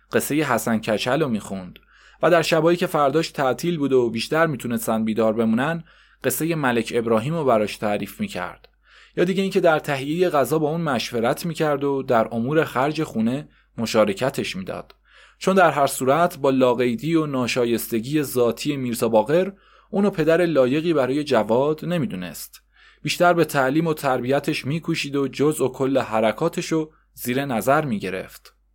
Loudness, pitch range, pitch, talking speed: -21 LUFS, 115-160 Hz, 140 Hz, 150 wpm